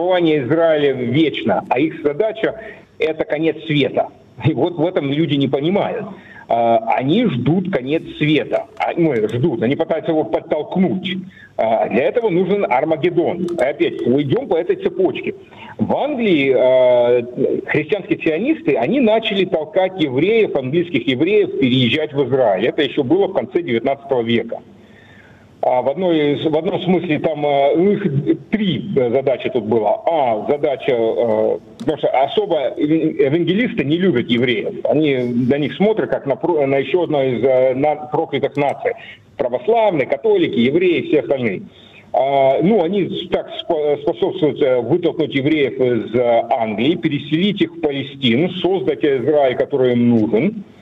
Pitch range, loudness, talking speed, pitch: 135-200 Hz, -17 LUFS, 130 wpm, 160 Hz